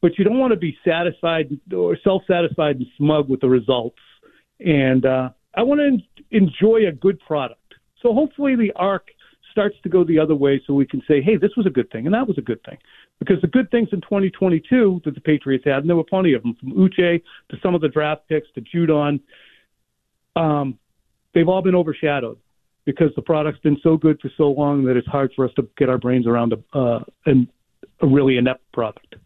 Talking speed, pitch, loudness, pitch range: 220 wpm, 155 Hz, -19 LUFS, 135-185 Hz